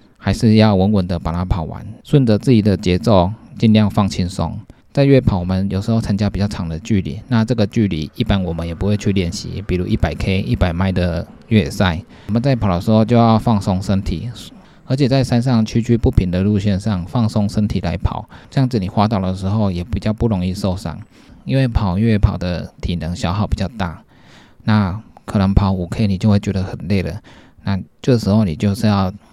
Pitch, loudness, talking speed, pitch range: 100 Hz, -17 LUFS, 310 characters per minute, 95-110 Hz